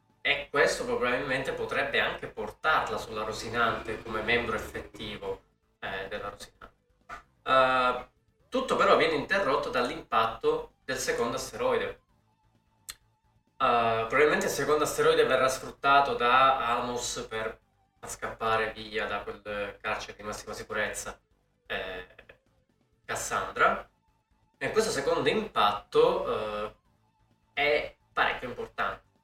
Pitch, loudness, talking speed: 125 Hz, -28 LUFS, 105 wpm